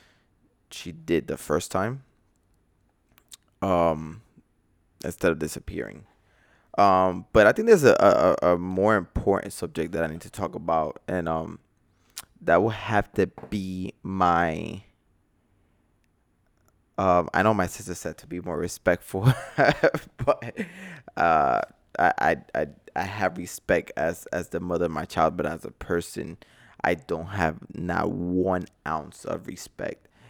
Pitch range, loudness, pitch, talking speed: 85-100 Hz, -25 LUFS, 90 Hz, 140 wpm